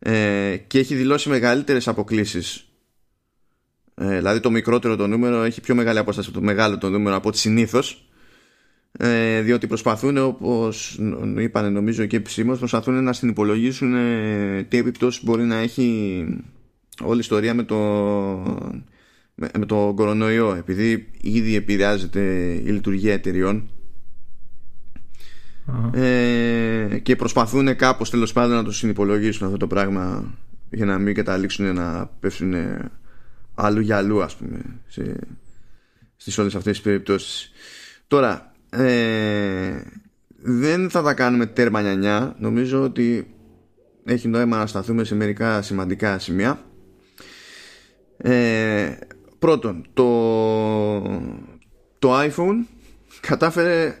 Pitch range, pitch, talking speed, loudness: 105-120 Hz, 110 Hz, 115 wpm, -21 LUFS